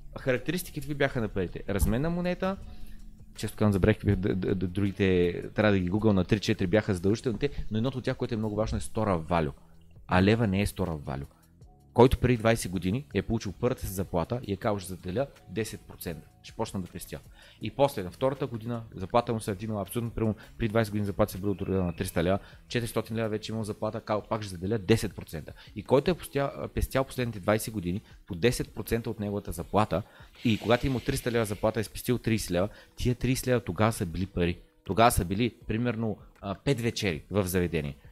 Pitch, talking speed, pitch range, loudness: 105 Hz, 215 wpm, 95-115 Hz, -29 LUFS